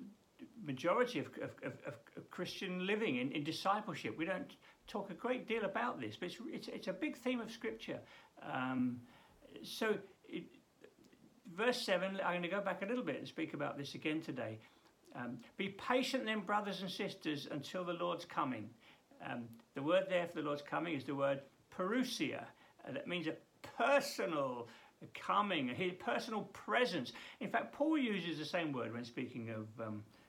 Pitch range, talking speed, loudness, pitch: 145-225 Hz, 175 wpm, -40 LUFS, 185 Hz